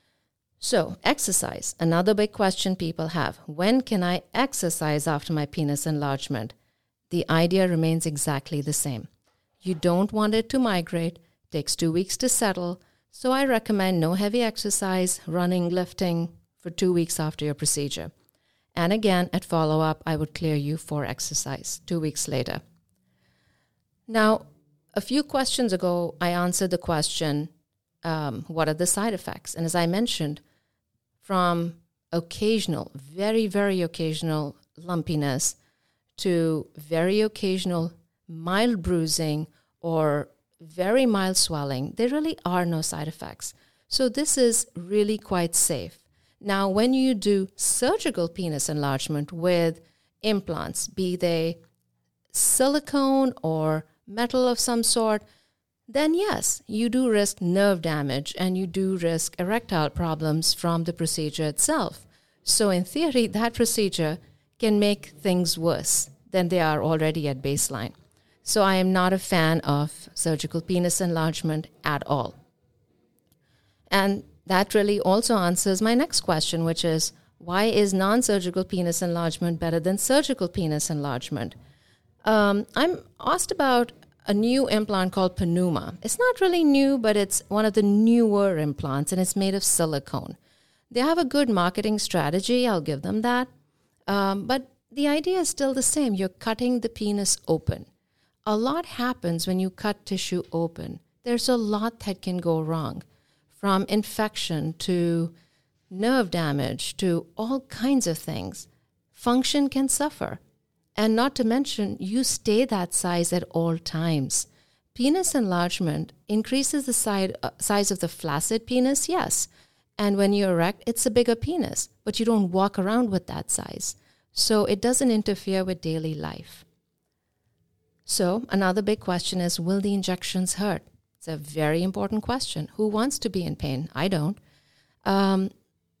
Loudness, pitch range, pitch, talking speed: -25 LUFS, 160-215 Hz, 180 Hz, 145 wpm